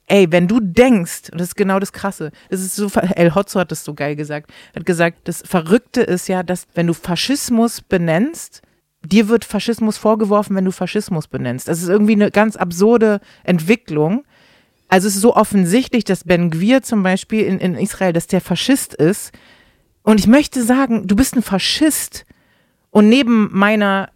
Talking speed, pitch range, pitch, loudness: 180 wpm, 180-225 Hz, 200 Hz, -16 LUFS